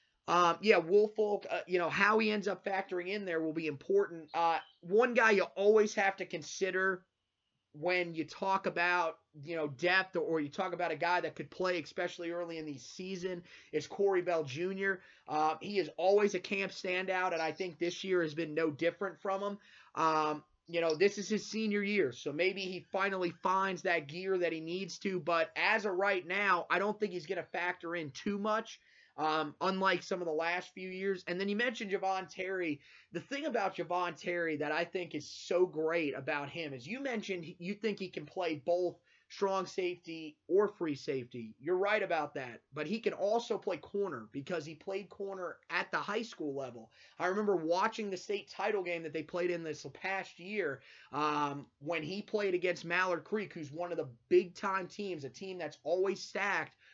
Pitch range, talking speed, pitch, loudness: 160-195 Hz, 205 wpm, 180 Hz, -34 LUFS